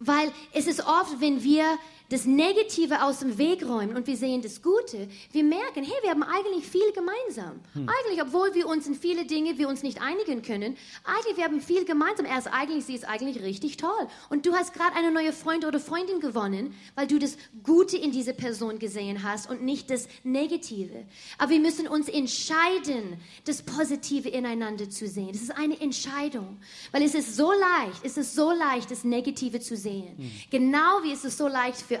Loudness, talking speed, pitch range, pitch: -27 LUFS, 200 wpm, 250-325 Hz, 285 Hz